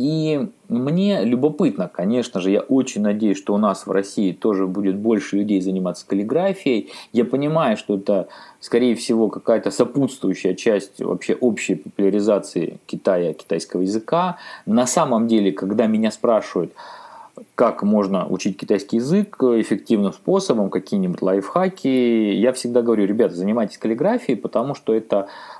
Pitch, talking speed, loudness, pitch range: 115 Hz, 135 wpm, -20 LUFS, 100-140 Hz